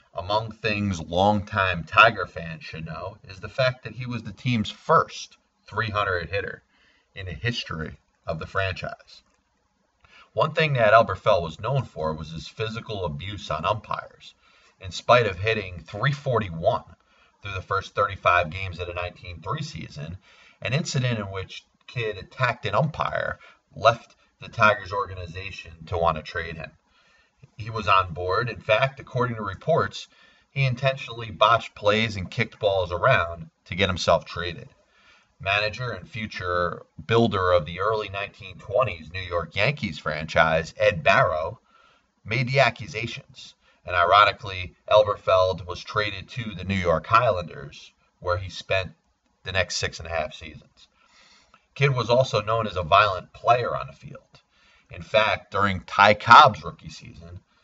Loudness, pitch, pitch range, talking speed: -23 LUFS, 100 Hz, 90-115 Hz, 150 wpm